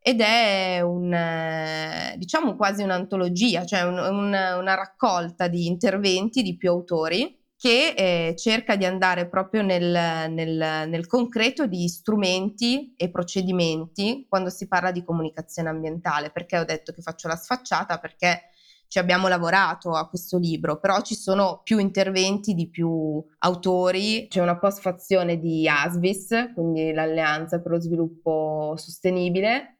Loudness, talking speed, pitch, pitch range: -23 LUFS, 140 wpm, 180 Hz, 165-195 Hz